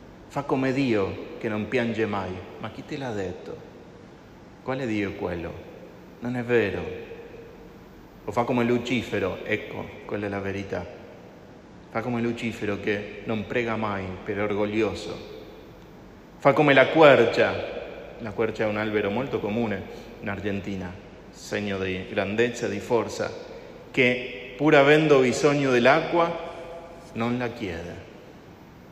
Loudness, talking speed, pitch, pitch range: -25 LUFS, 135 wpm, 115 Hz, 105-135 Hz